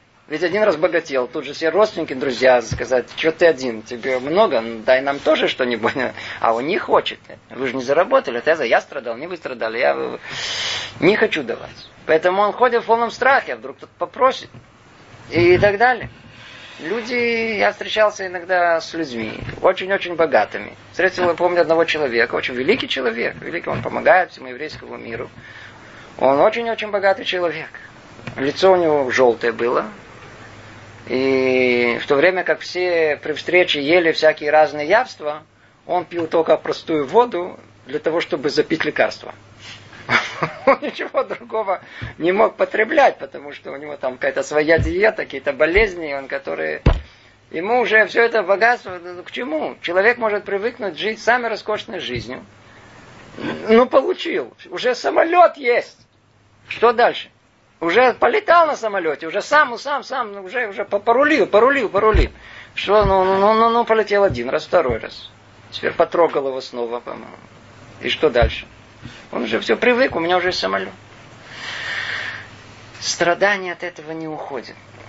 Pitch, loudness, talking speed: 160 Hz, -18 LUFS, 150 wpm